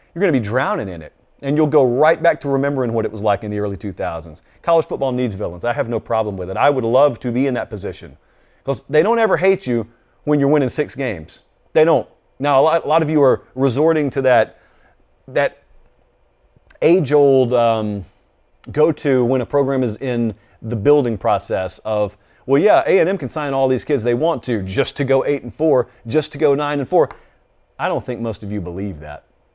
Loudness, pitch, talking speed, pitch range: -18 LUFS, 130 Hz, 215 wpm, 110-145 Hz